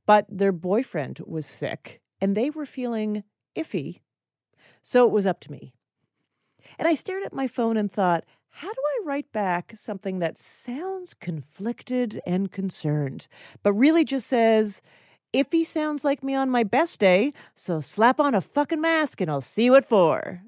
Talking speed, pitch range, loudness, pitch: 170 wpm, 185-270 Hz, -24 LUFS, 220 Hz